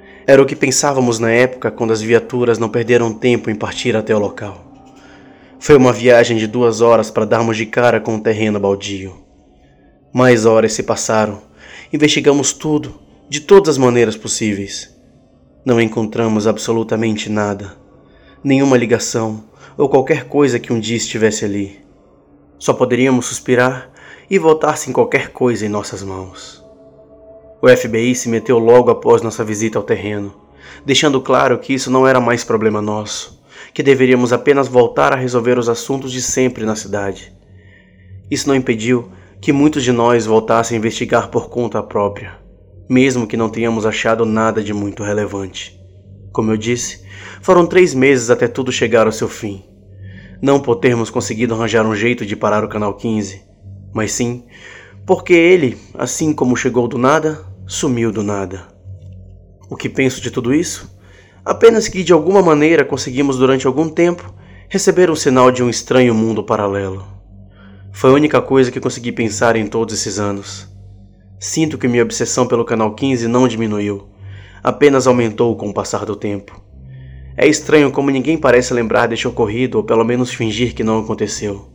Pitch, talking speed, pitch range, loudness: 115 Hz, 165 wpm, 100-130 Hz, -14 LUFS